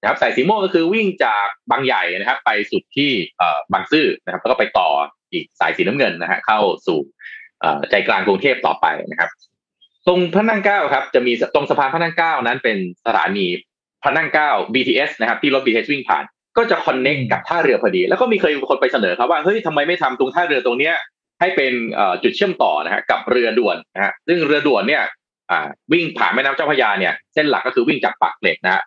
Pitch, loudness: 180 Hz, -17 LUFS